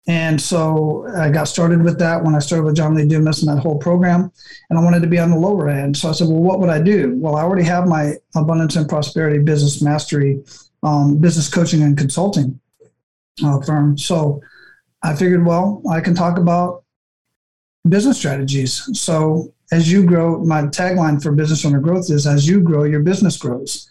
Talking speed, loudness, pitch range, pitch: 200 wpm, -16 LUFS, 150-175 Hz, 160 Hz